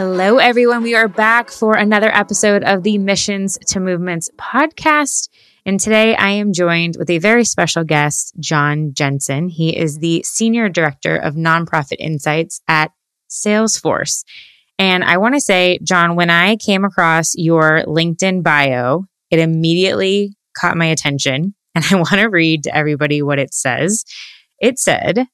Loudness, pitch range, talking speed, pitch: -14 LUFS, 160-210 Hz, 155 wpm, 180 Hz